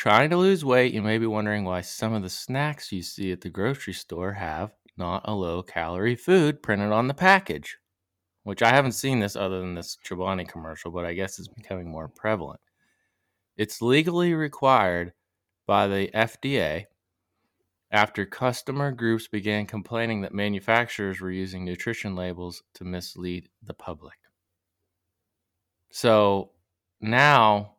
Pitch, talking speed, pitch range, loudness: 100 Hz, 150 wpm, 90-115 Hz, -25 LUFS